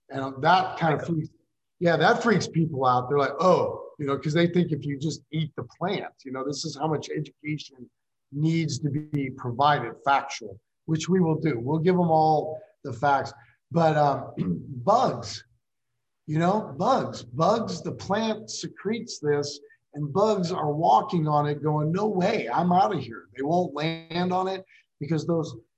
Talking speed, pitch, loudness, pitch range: 180 wpm, 155 Hz, -25 LUFS, 140-175 Hz